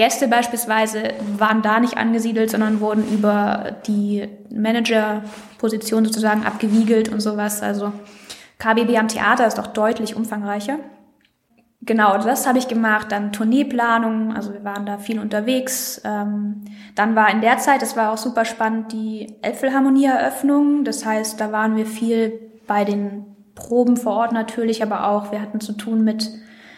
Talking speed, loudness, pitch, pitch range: 150 wpm, -19 LUFS, 220 Hz, 210-230 Hz